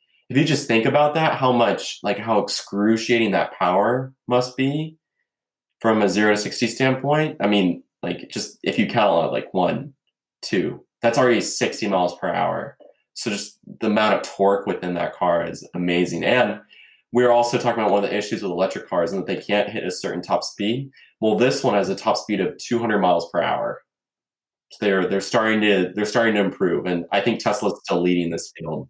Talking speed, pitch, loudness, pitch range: 210 wpm, 110 Hz, -21 LUFS, 100-125 Hz